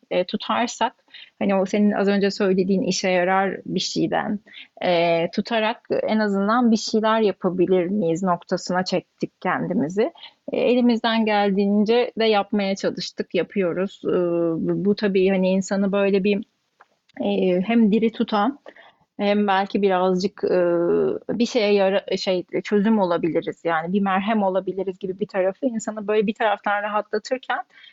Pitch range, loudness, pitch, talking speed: 185-220 Hz, -22 LUFS, 200 Hz, 135 wpm